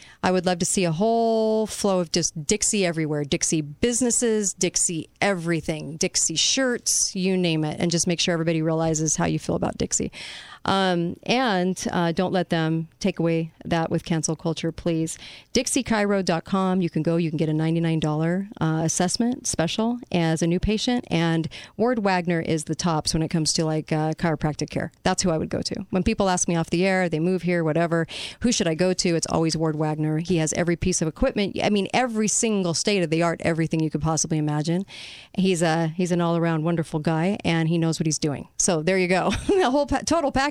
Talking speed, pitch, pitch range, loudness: 215 wpm, 170 Hz, 160-195 Hz, -23 LUFS